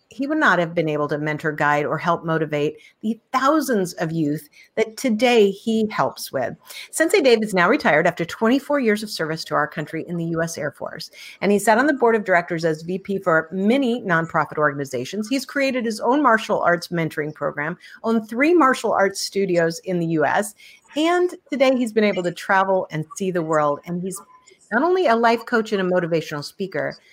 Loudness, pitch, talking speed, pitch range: -21 LUFS, 190 Hz, 205 wpm, 160-235 Hz